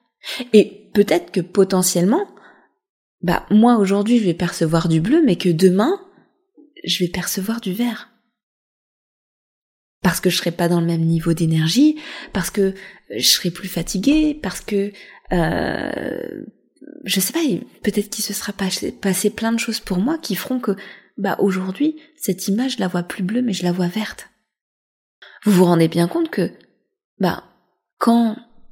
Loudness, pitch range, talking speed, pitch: -19 LUFS, 185-245 Hz, 160 wpm, 205 Hz